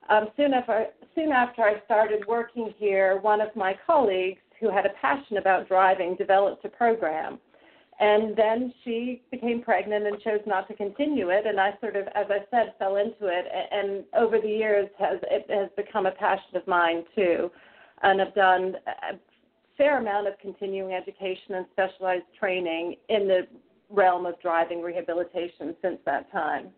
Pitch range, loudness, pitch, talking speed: 190-220 Hz, -26 LUFS, 200 Hz, 175 wpm